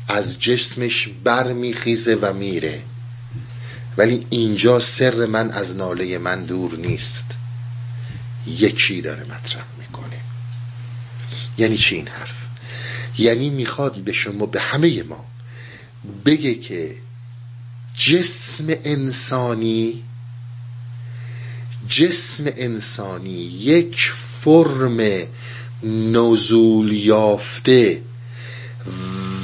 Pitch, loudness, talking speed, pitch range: 120 Hz, -18 LUFS, 80 wpm, 115-120 Hz